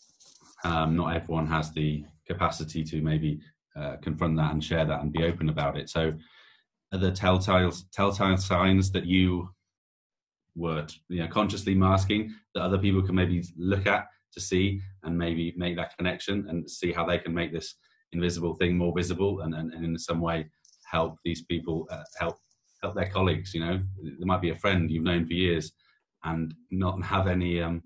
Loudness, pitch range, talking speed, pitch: -28 LUFS, 80-95 Hz, 185 wpm, 85 Hz